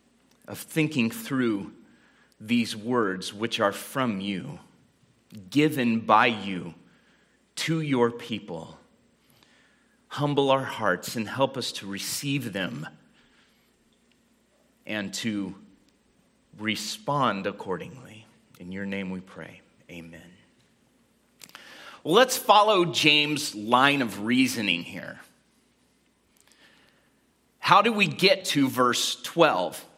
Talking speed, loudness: 100 wpm, -25 LUFS